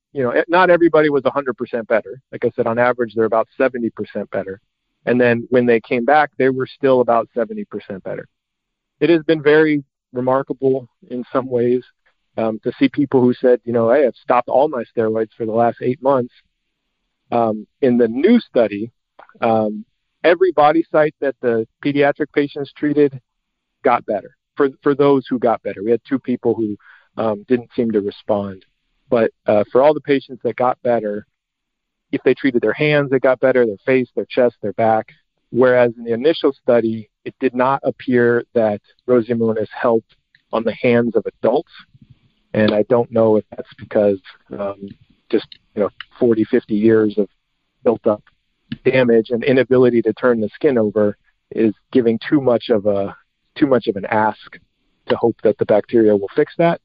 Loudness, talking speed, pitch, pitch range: -17 LUFS, 180 wpm, 120 Hz, 110-135 Hz